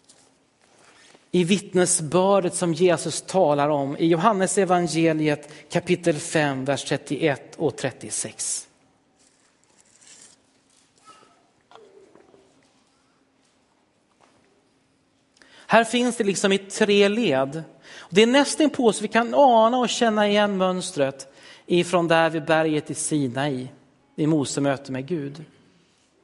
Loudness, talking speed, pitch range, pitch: -22 LUFS, 105 wpm, 145-205 Hz, 175 Hz